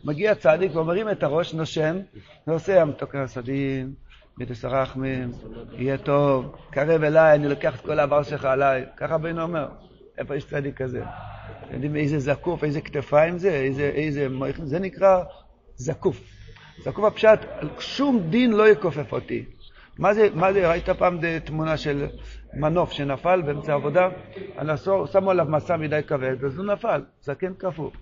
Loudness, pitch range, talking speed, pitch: -23 LUFS, 135-180 Hz, 145 wpm, 150 Hz